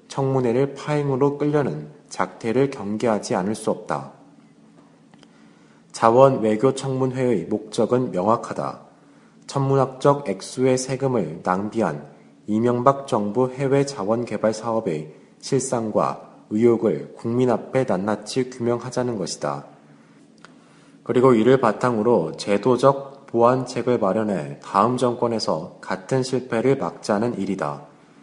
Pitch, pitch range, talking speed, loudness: 120 Hz, 105-130 Hz, 260 characters per minute, -22 LUFS